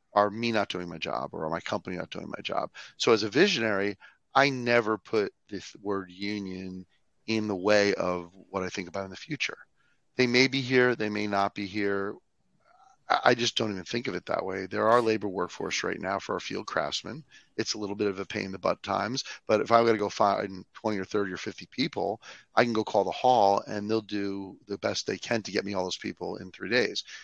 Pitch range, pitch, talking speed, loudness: 95-110 Hz, 100 Hz, 240 wpm, -28 LUFS